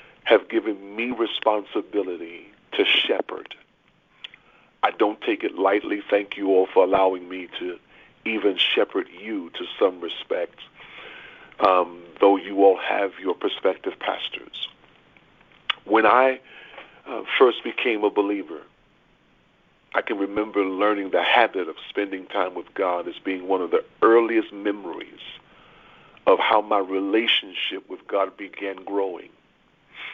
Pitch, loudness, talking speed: 105 Hz, -23 LUFS, 130 wpm